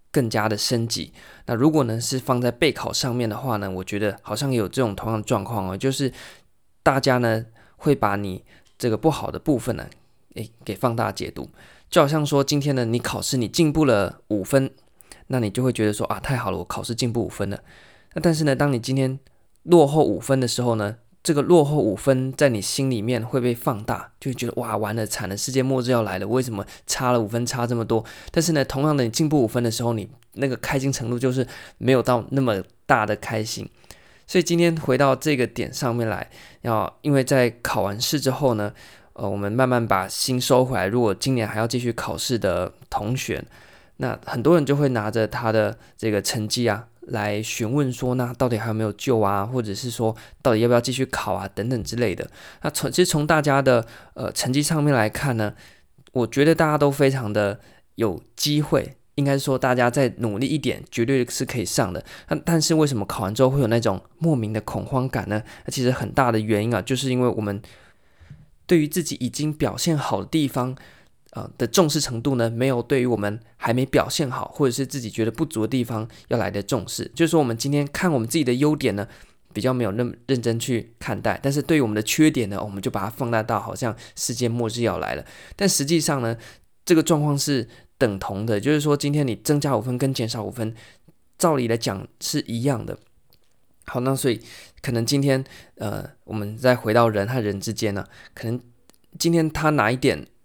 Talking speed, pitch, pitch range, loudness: 310 characters per minute, 125 Hz, 110-140 Hz, -23 LUFS